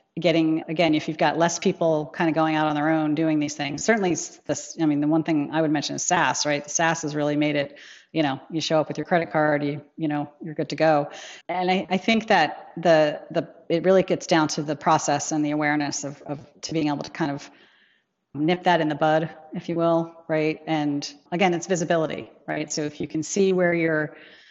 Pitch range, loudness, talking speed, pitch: 150-170 Hz, -23 LUFS, 240 wpm, 155 Hz